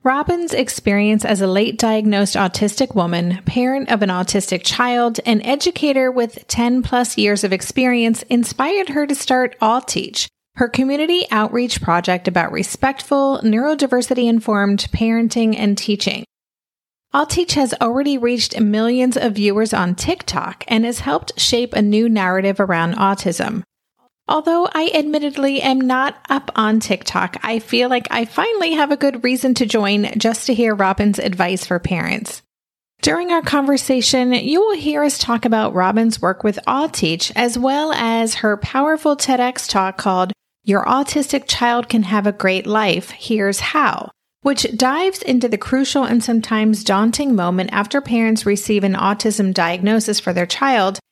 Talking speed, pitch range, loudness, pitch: 155 wpm, 205-265 Hz, -17 LUFS, 230 Hz